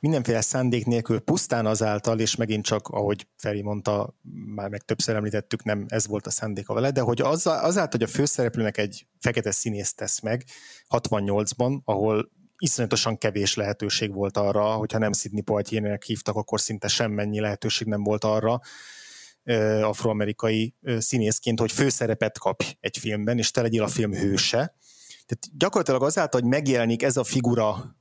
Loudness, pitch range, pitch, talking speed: -25 LUFS, 105-120 Hz, 110 Hz, 160 wpm